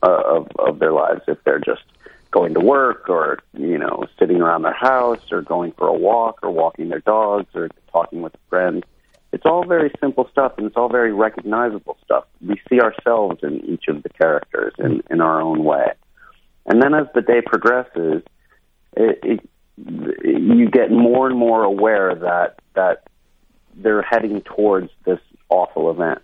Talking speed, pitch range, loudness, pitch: 175 wpm, 95-130 Hz, -18 LUFS, 115 Hz